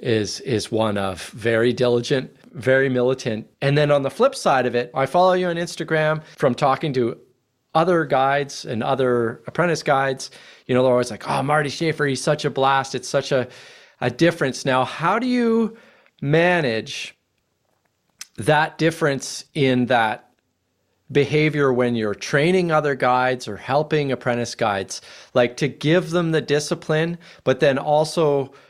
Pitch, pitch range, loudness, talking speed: 135 Hz, 125-155 Hz, -20 LUFS, 155 wpm